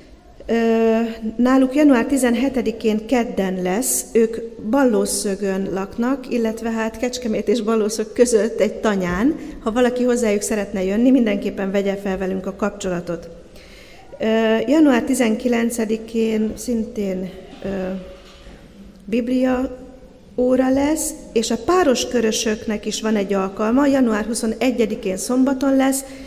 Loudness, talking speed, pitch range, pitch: -19 LUFS, 105 wpm, 205-250 Hz, 225 Hz